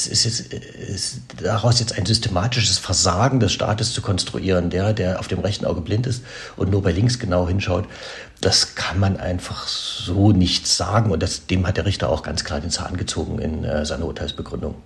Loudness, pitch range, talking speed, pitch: -21 LUFS, 90-110 Hz, 195 wpm, 95 Hz